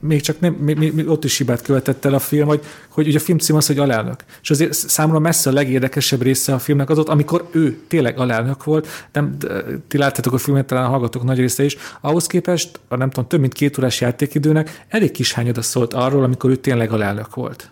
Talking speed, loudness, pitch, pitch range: 235 wpm, -17 LUFS, 140 Hz, 130-155 Hz